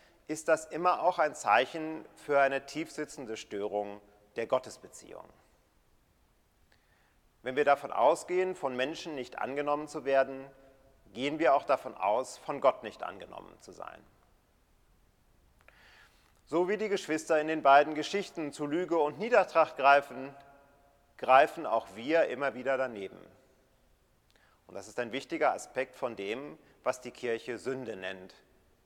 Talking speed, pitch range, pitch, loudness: 135 wpm, 130-155 Hz, 140 Hz, -30 LUFS